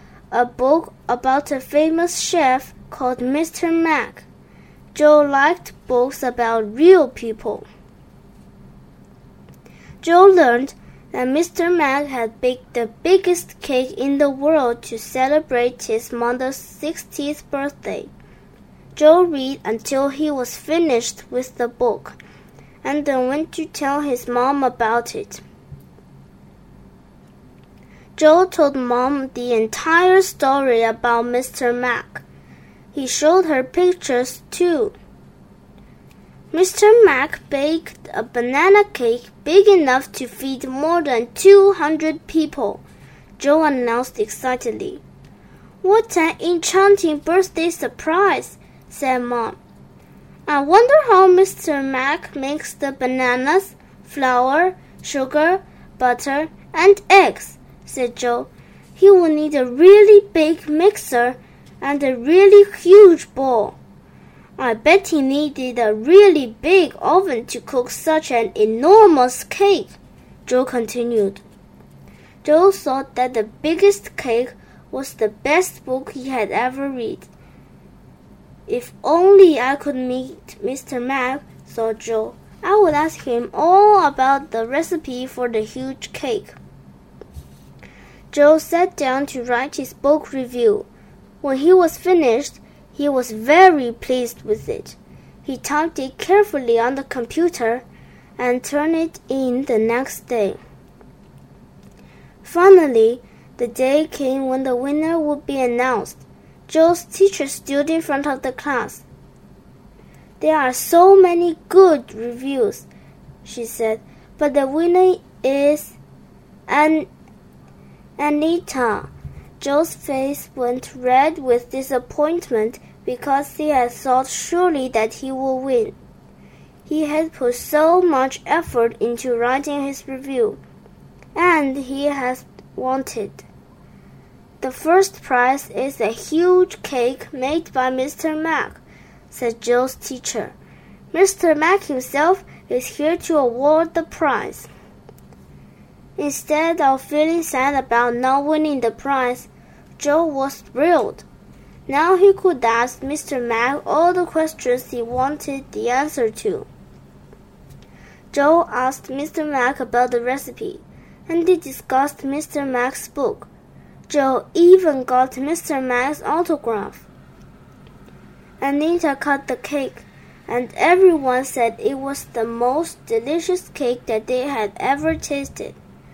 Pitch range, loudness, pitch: 250-330 Hz, -17 LUFS, 280 Hz